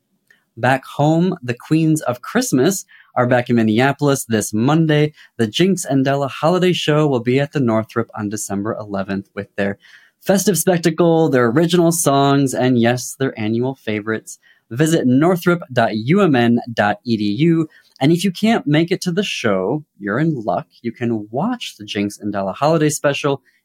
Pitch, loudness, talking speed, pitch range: 135 Hz, -17 LUFS, 155 wpm, 115-165 Hz